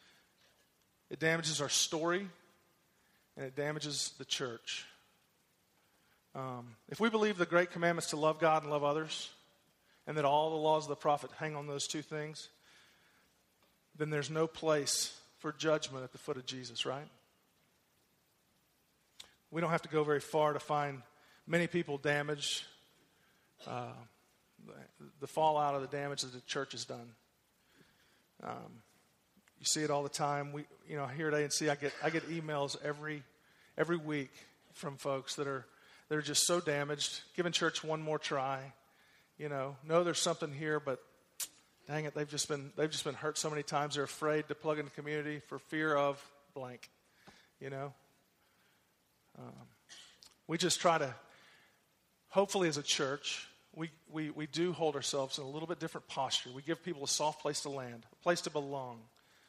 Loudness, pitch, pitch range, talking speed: -36 LUFS, 150 Hz, 140-155 Hz, 175 wpm